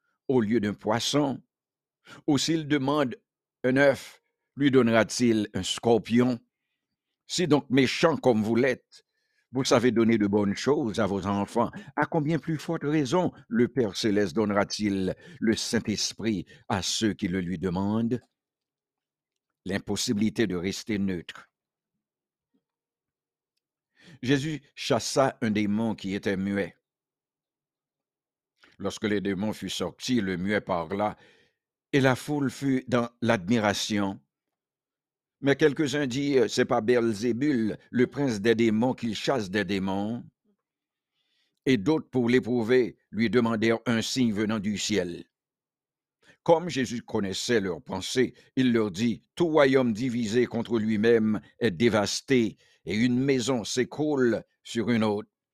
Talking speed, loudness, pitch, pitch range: 125 wpm, -26 LUFS, 115 Hz, 105-135 Hz